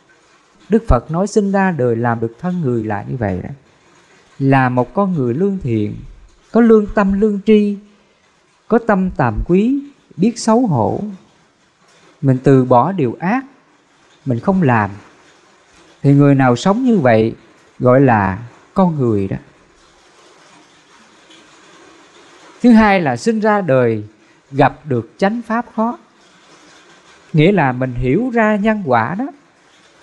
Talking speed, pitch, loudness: 140 wpm, 175 Hz, -15 LUFS